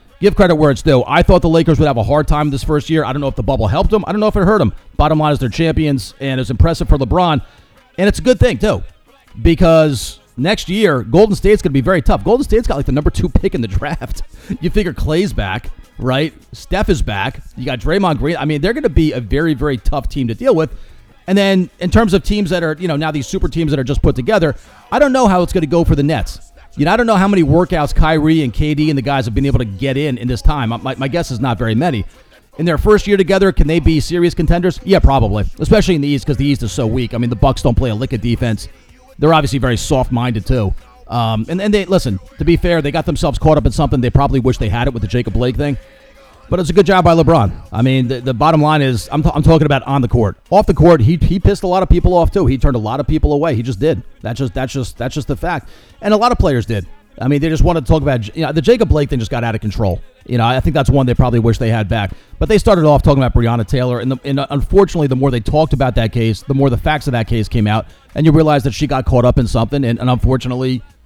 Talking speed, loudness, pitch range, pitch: 295 wpm, -14 LUFS, 125-165 Hz, 140 Hz